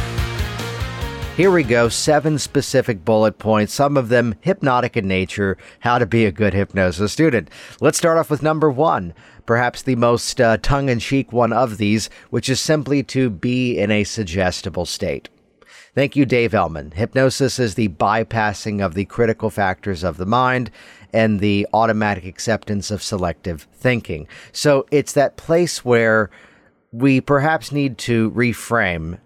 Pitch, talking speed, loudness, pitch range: 115 Hz, 160 wpm, -18 LUFS, 105-130 Hz